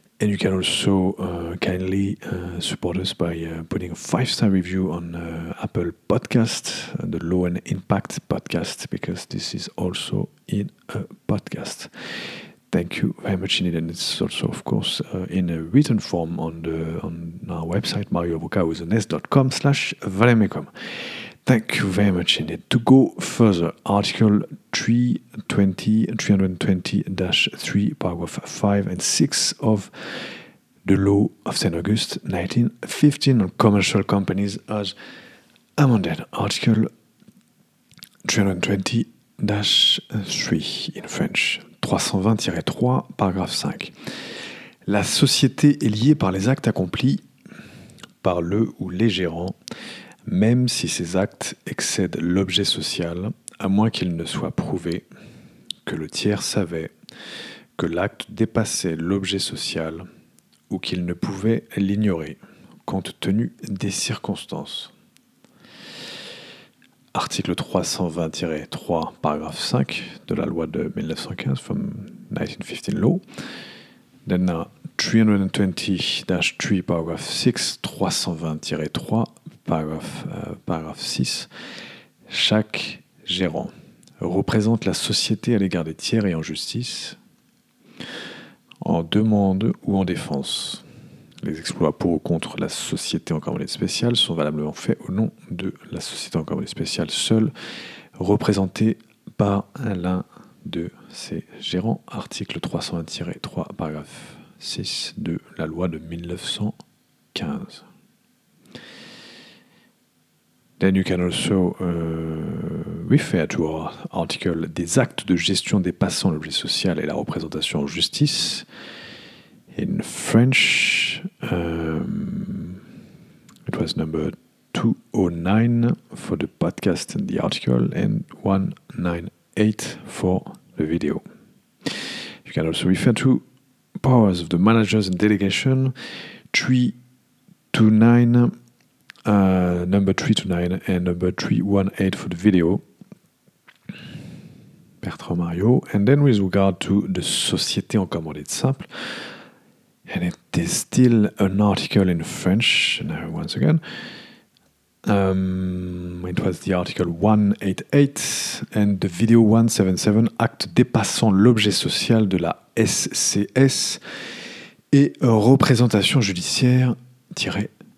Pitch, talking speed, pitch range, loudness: 100 Hz, 115 wpm, 90-115 Hz, -22 LUFS